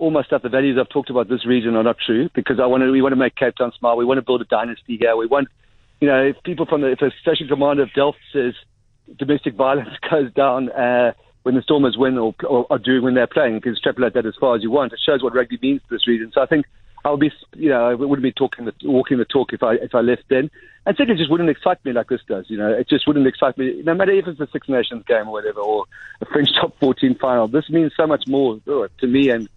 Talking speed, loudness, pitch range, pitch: 285 wpm, -18 LUFS, 120-145 Hz, 130 Hz